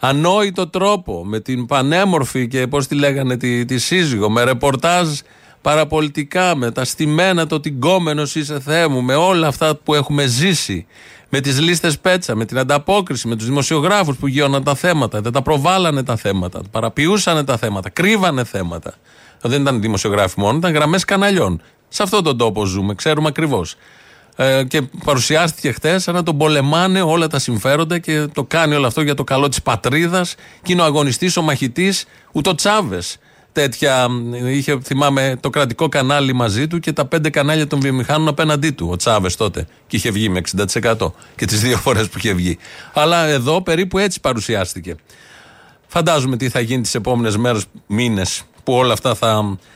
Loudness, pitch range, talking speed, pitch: -16 LUFS, 120-160 Hz, 170 wpm, 140 Hz